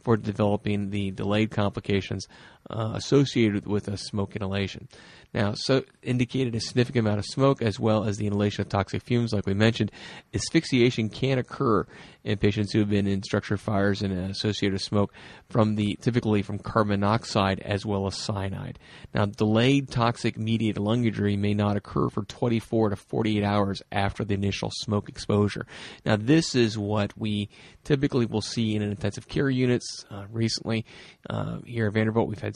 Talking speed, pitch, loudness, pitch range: 175 wpm, 105 Hz, -26 LUFS, 100-115 Hz